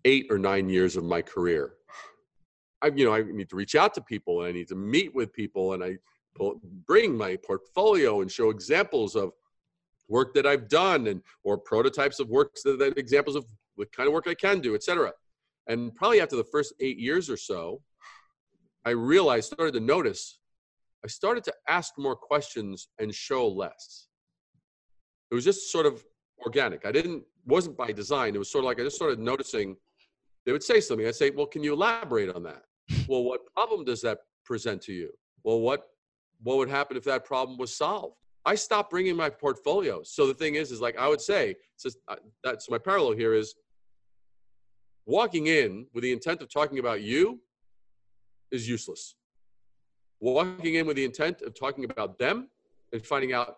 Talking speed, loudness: 190 wpm, -27 LUFS